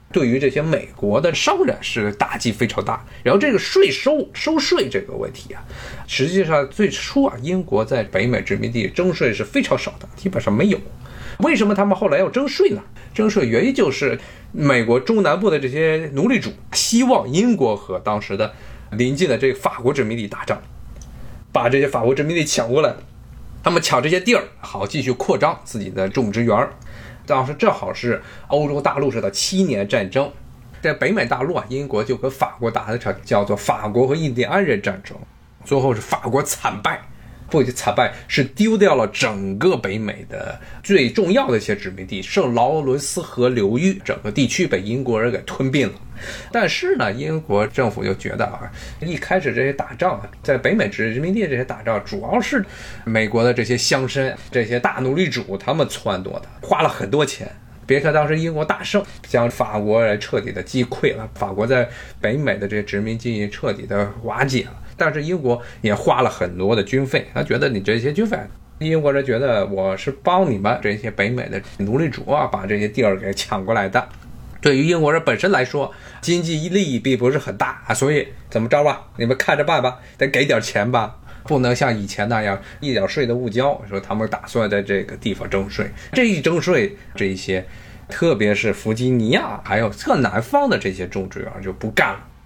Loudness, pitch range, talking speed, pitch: -19 LUFS, 105-155 Hz, 295 characters per minute, 125 Hz